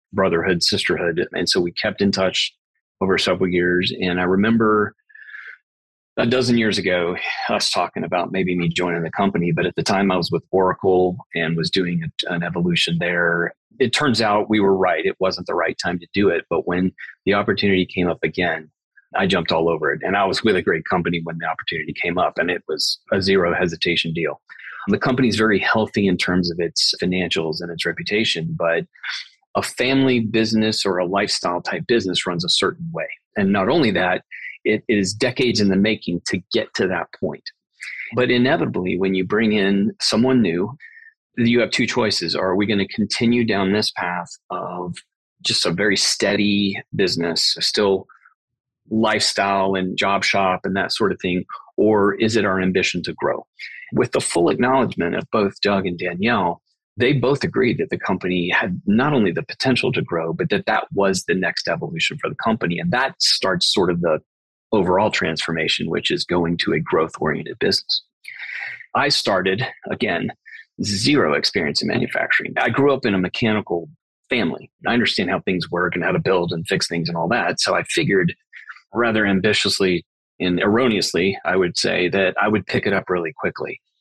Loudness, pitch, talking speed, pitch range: -20 LUFS, 95 Hz, 190 wpm, 85-110 Hz